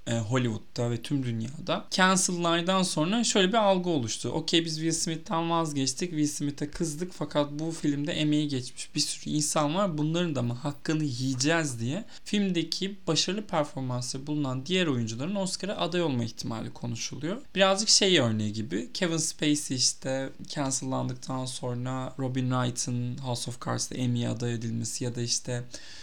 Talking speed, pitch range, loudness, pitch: 150 wpm, 125-170 Hz, -28 LUFS, 150 Hz